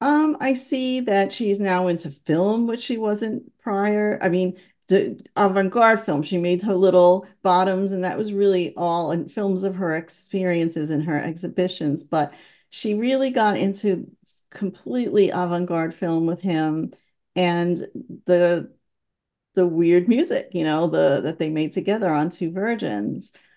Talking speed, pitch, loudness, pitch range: 155 wpm, 185 Hz, -22 LUFS, 170-205 Hz